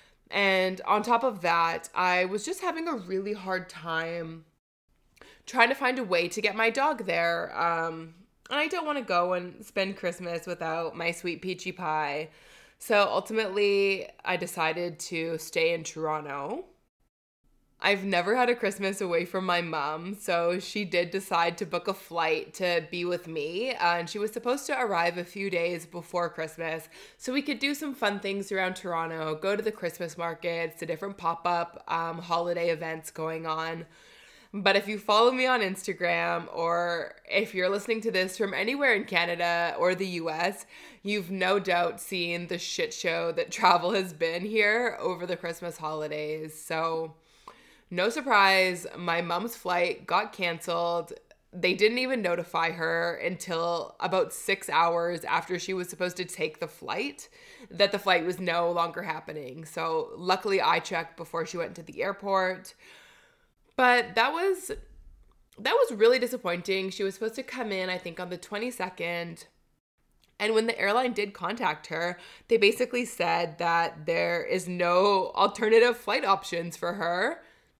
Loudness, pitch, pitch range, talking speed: -28 LUFS, 180 Hz, 170-210 Hz, 165 wpm